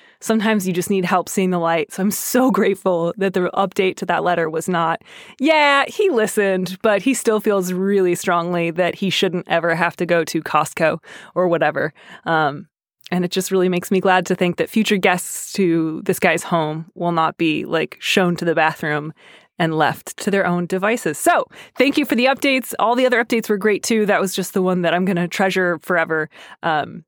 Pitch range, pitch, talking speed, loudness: 170-210 Hz, 185 Hz, 215 wpm, -18 LUFS